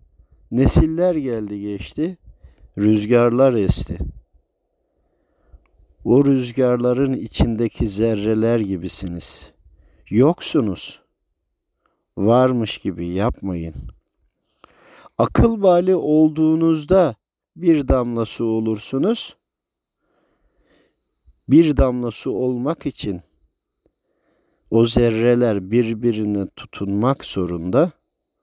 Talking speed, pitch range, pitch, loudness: 65 wpm, 95-135 Hz, 115 Hz, -19 LUFS